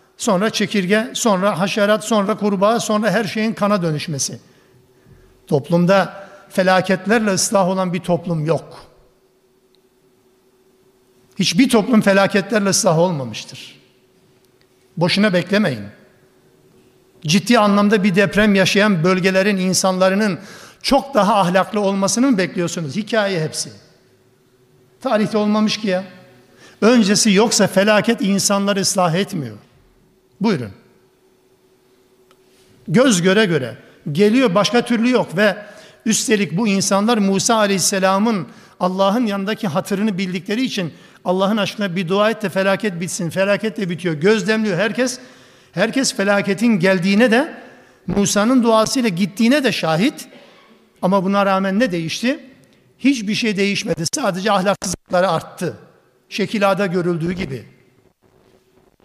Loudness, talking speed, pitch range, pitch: -17 LUFS, 105 wpm, 175-215 Hz, 195 Hz